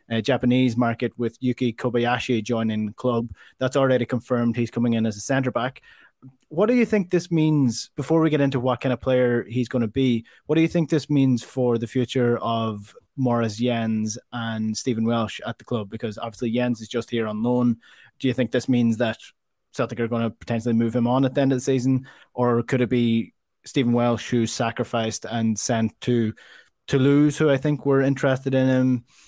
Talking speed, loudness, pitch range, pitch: 210 wpm, -23 LUFS, 115-130 Hz, 125 Hz